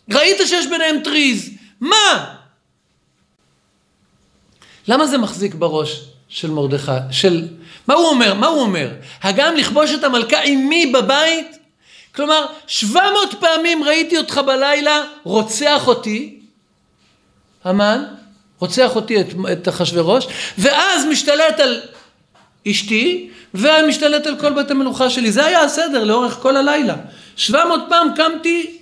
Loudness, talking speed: -15 LUFS, 120 wpm